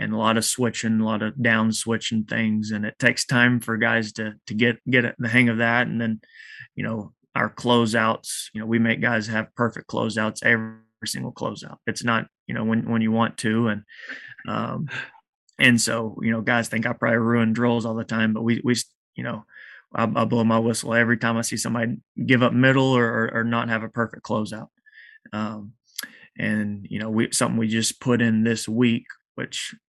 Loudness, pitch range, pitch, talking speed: -23 LUFS, 110-120 Hz, 115 Hz, 210 wpm